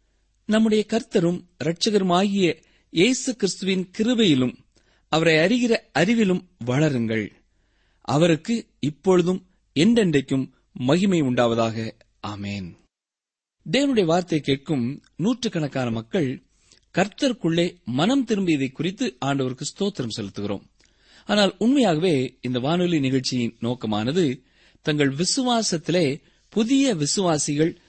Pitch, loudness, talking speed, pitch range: 160 Hz, -22 LUFS, 80 wpm, 125-200 Hz